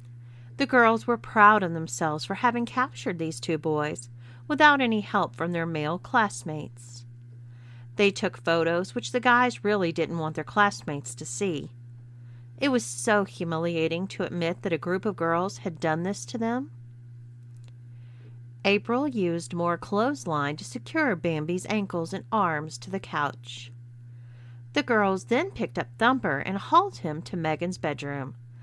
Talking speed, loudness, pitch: 155 wpm, -26 LUFS, 165 Hz